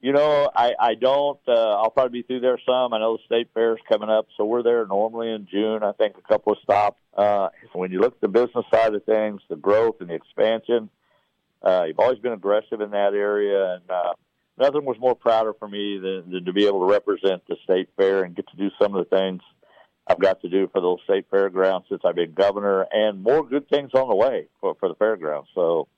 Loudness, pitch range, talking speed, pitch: -22 LUFS, 100-125 Hz, 245 wpm, 110 Hz